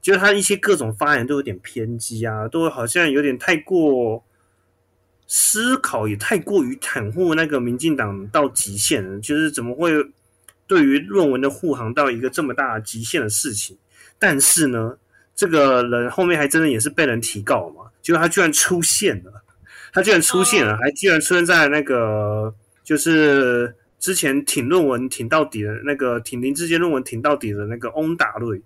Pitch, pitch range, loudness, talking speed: 130 Hz, 110-160 Hz, -18 LUFS, 270 characters per minute